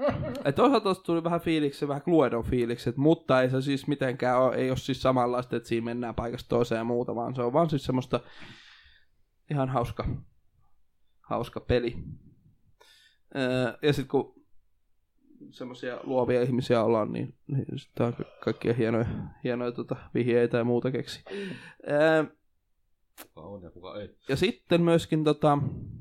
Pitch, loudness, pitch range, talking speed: 125 Hz, -28 LUFS, 120-145 Hz, 135 wpm